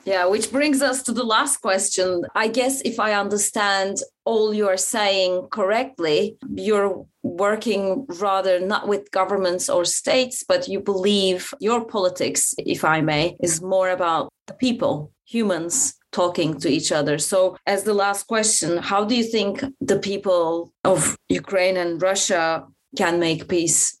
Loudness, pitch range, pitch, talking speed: -21 LUFS, 180-220 Hz, 195 Hz, 155 wpm